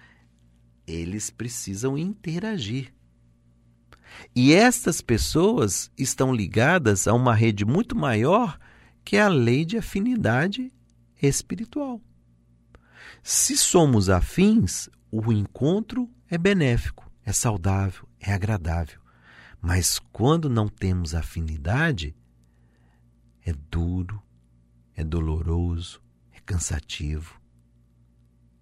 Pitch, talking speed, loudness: 95 Hz, 90 wpm, -23 LUFS